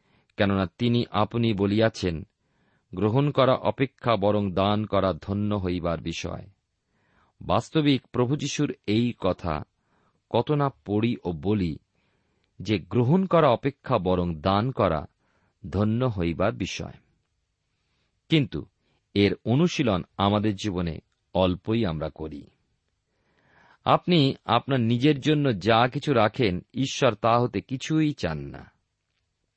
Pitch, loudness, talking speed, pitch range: 105 Hz, -25 LUFS, 110 wpm, 95-130 Hz